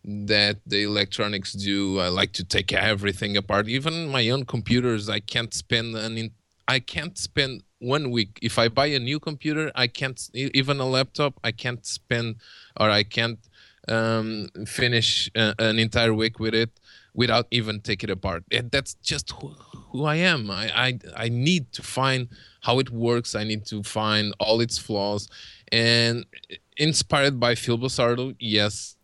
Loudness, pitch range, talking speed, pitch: -24 LUFS, 105-130 Hz, 170 wpm, 115 Hz